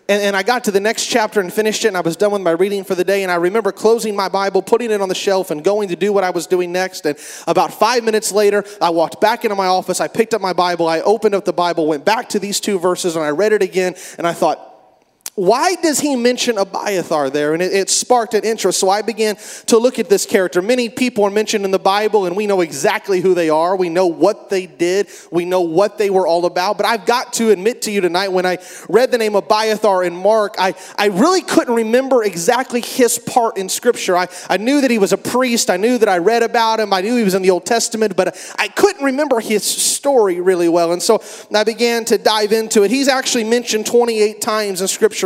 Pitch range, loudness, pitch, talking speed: 185-230 Hz, -16 LUFS, 205 Hz, 260 wpm